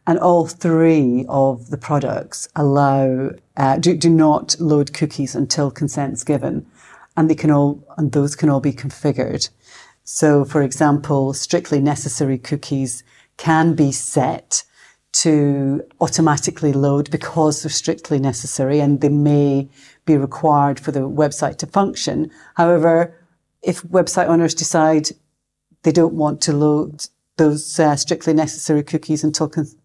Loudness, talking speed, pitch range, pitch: -17 LUFS, 140 wpm, 140-160 Hz, 150 Hz